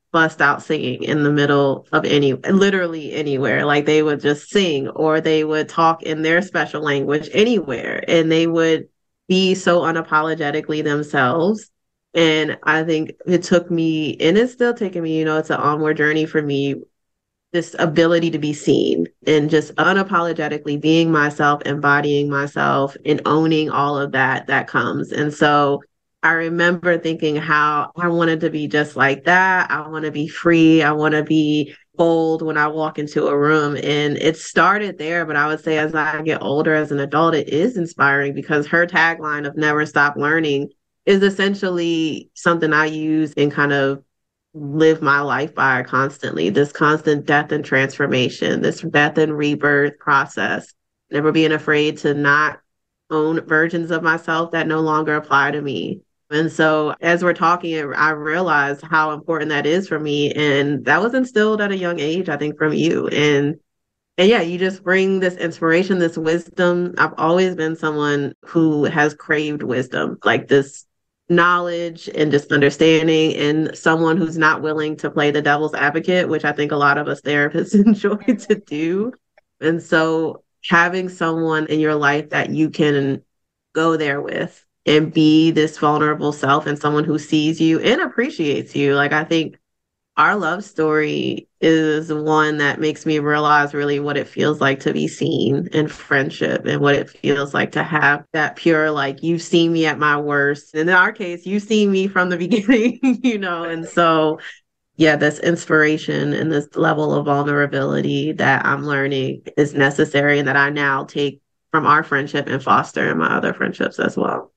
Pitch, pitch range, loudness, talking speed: 155 Hz, 145-165 Hz, -17 LUFS, 175 wpm